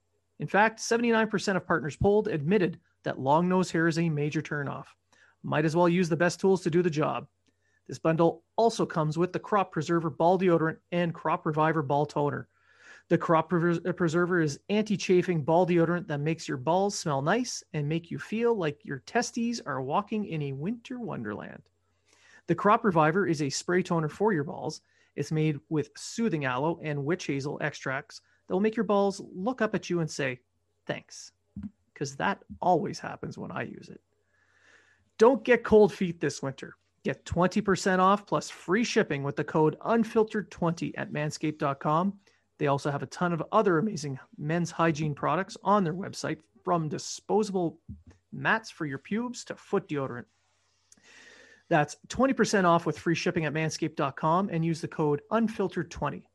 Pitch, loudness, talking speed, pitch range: 170 Hz, -28 LUFS, 170 wpm, 155-200 Hz